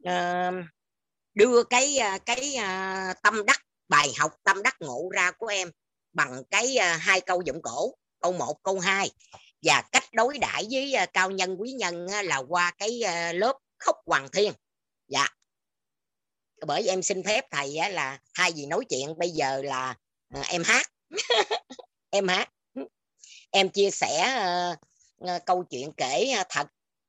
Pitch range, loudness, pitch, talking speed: 170-215 Hz, -26 LUFS, 185 Hz, 170 wpm